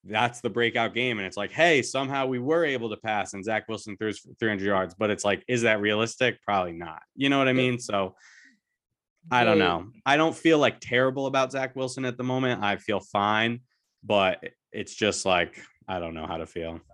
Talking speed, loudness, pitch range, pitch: 215 wpm, -26 LUFS, 100-130 Hz, 115 Hz